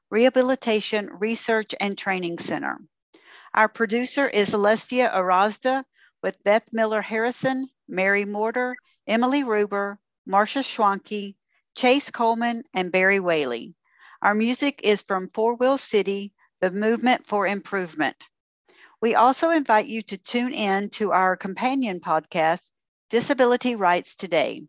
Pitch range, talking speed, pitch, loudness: 200-250 Hz, 120 wpm, 215 Hz, -23 LUFS